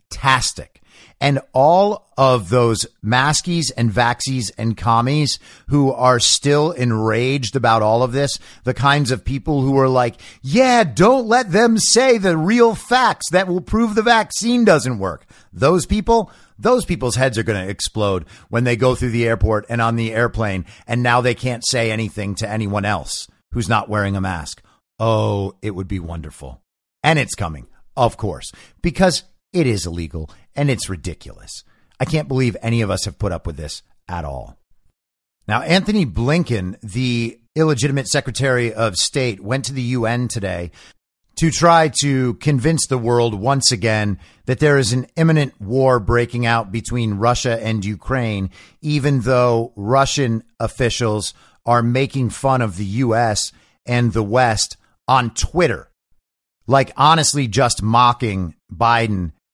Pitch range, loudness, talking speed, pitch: 105-140 Hz, -17 LUFS, 155 wpm, 120 Hz